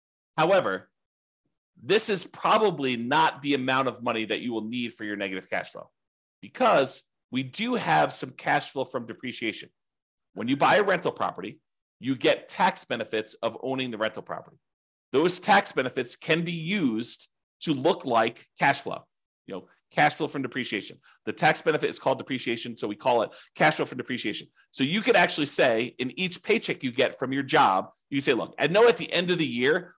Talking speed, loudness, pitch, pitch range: 195 wpm, -25 LUFS, 135 Hz, 120-180 Hz